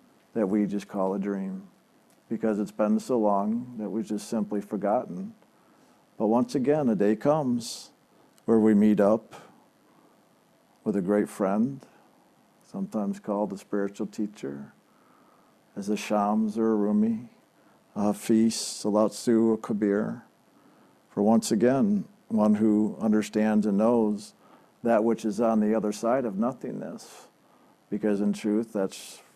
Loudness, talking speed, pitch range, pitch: -26 LUFS, 140 wpm, 105-115 Hz, 110 Hz